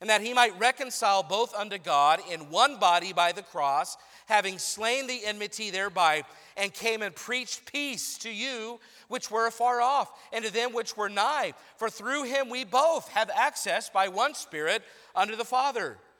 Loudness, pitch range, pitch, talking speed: -28 LUFS, 200-250 Hz, 225 Hz, 180 wpm